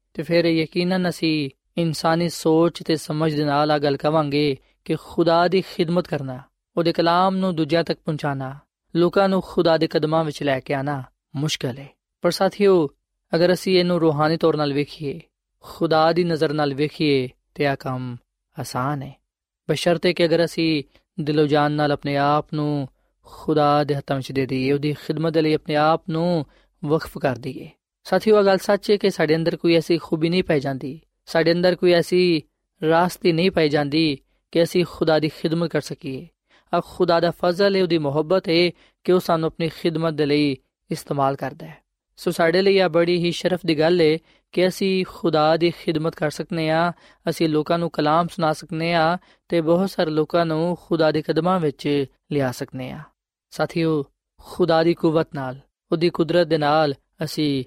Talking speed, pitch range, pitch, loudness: 170 wpm, 150-175 Hz, 160 Hz, -21 LUFS